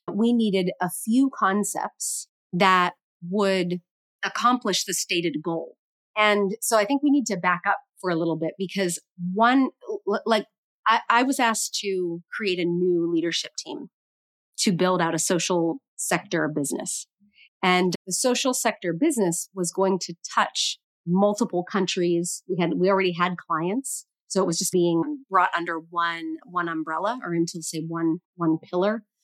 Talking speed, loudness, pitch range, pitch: 160 wpm, -24 LUFS, 170-205 Hz, 185 Hz